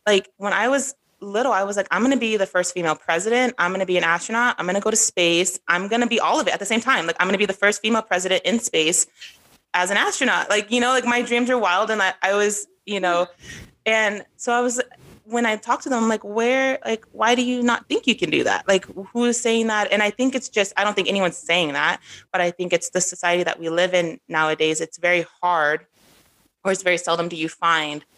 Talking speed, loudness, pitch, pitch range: 260 wpm, -20 LUFS, 200 Hz, 175-235 Hz